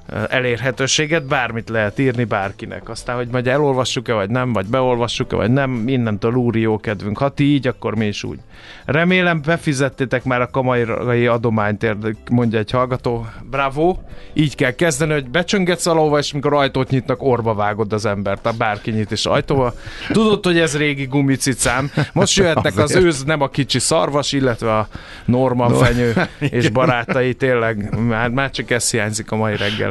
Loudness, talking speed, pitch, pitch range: -18 LUFS, 165 wpm, 125 Hz, 115-145 Hz